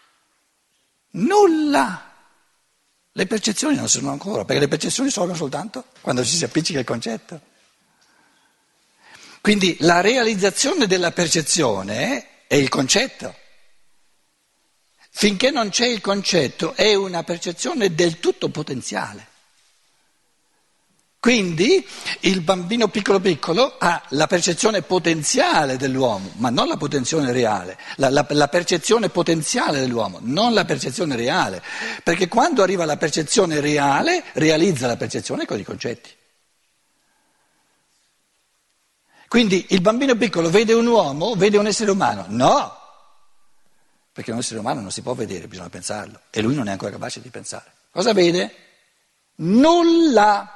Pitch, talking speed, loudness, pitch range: 185 Hz, 125 wpm, -19 LUFS, 160-230 Hz